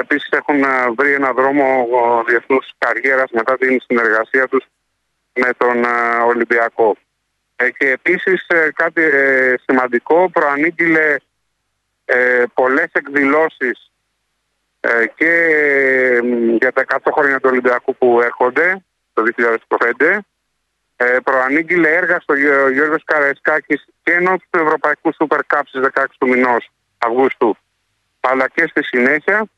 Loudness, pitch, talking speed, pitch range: -14 LUFS, 130 Hz, 105 wpm, 125-155 Hz